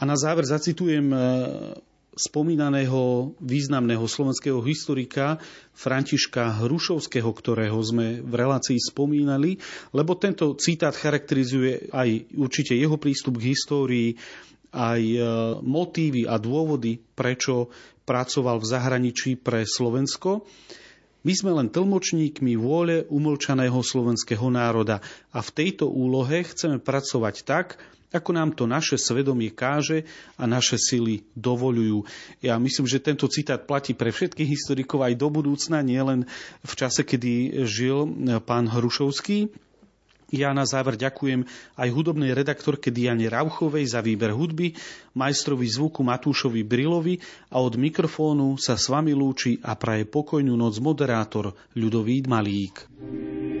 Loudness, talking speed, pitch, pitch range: -24 LUFS, 120 wpm, 135 Hz, 120-150 Hz